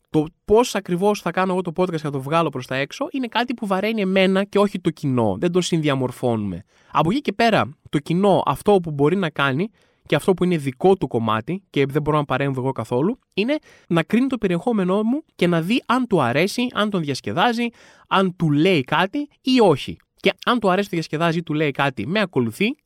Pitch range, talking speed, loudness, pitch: 145-205 Hz, 225 wpm, -21 LUFS, 180 Hz